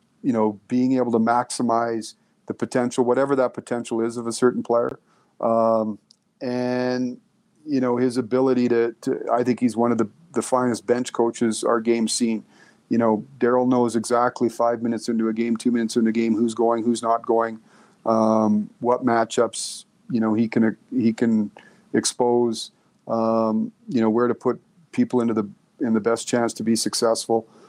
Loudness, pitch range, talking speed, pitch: -22 LUFS, 115-125 Hz, 180 wpm, 115 Hz